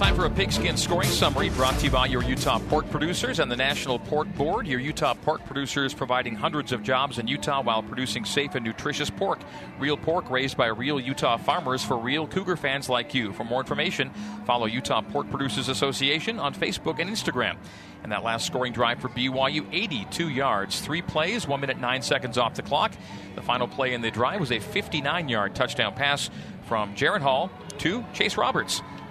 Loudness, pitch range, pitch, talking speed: -26 LUFS, 120-145 Hz, 130 Hz, 200 wpm